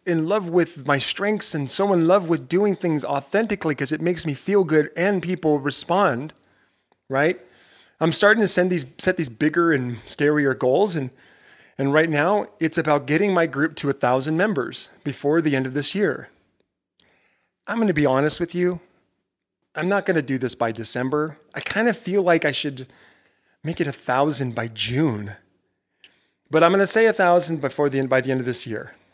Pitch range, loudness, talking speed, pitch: 140-180 Hz, -21 LUFS, 195 wpm, 155 Hz